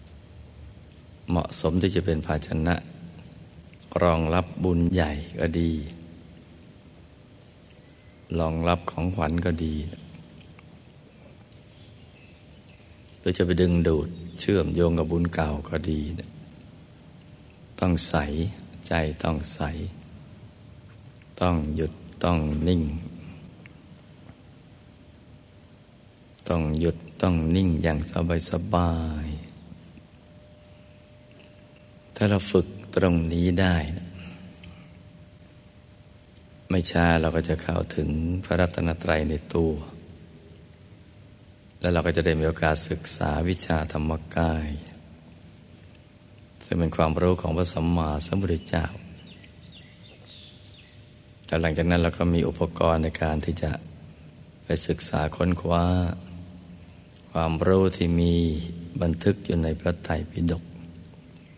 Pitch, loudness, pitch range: 85 Hz, -26 LUFS, 80-90 Hz